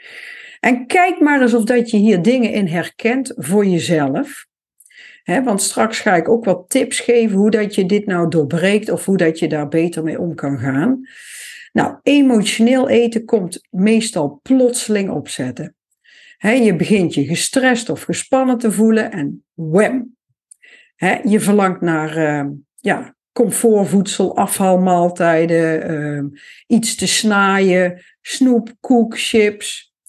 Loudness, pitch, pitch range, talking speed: -16 LUFS, 210 Hz, 170-240 Hz, 130 wpm